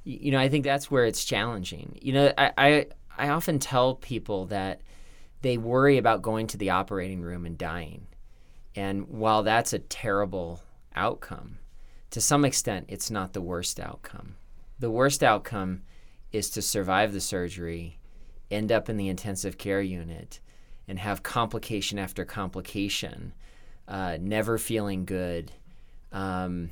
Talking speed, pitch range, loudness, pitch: 150 wpm, 90-115 Hz, -27 LUFS, 100 Hz